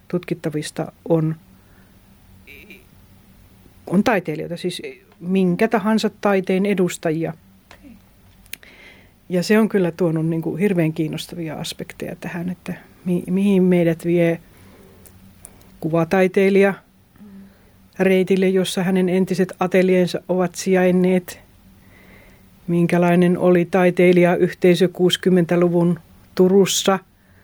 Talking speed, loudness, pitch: 85 wpm, -19 LUFS, 175 Hz